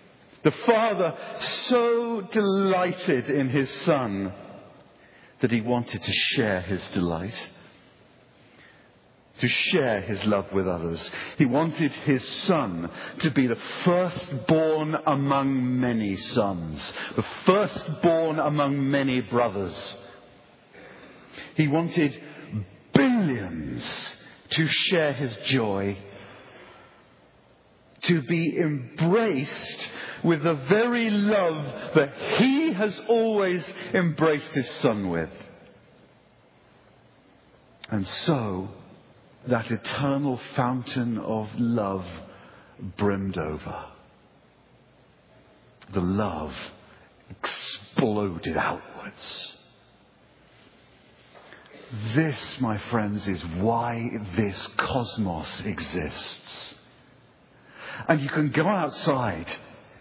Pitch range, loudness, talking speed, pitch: 100-160 Hz, -25 LUFS, 85 wpm, 130 Hz